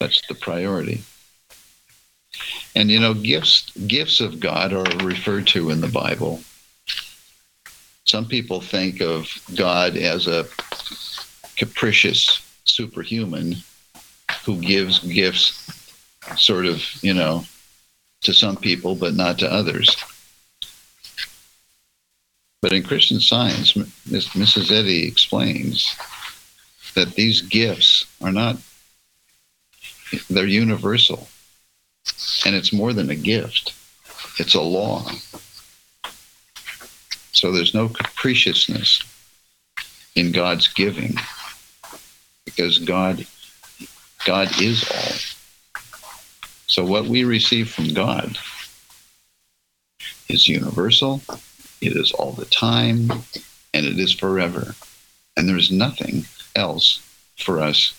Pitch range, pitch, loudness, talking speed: 85-110 Hz, 95 Hz, -18 LUFS, 100 wpm